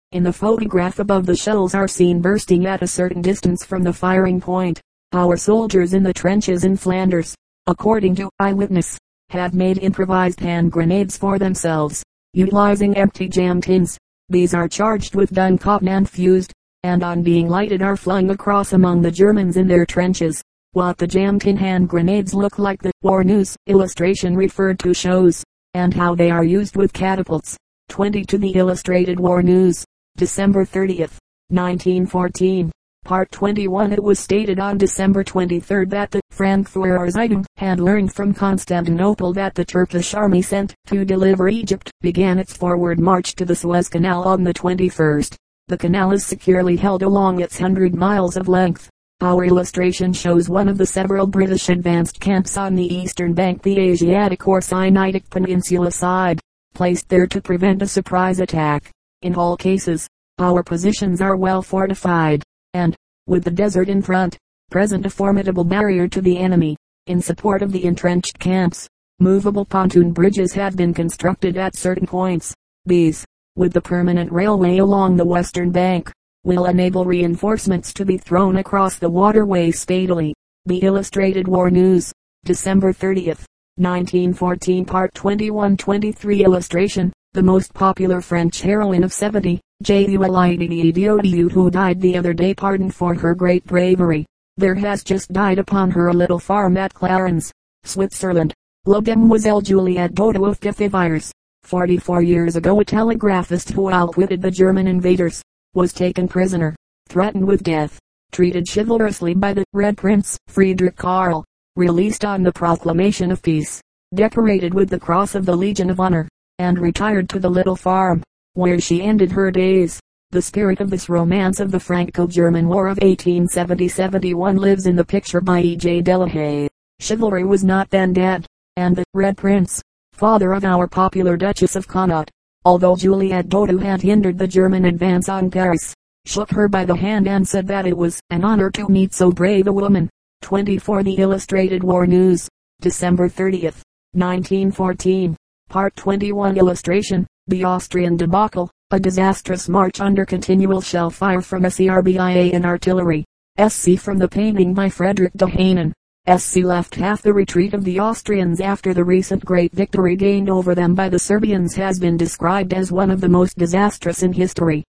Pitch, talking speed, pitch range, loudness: 185 Hz, 160 wpm, 180-195 Hz, -17 LUFS